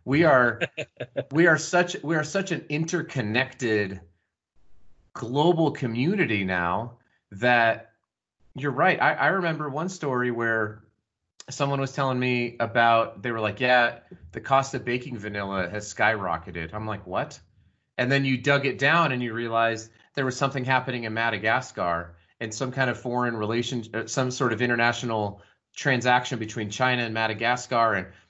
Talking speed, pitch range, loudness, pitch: 155 wpm, 110-130 Hz, -25 LUFS, 120 Hz